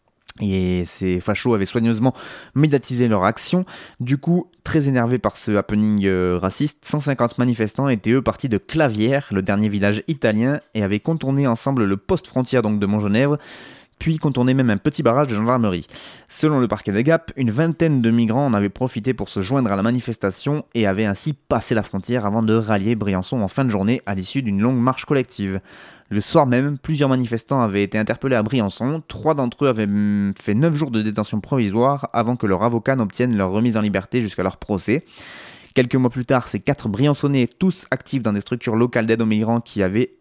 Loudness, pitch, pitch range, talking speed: -20 LUFS, 120 Hz, 105-135 Hz, 200 wpm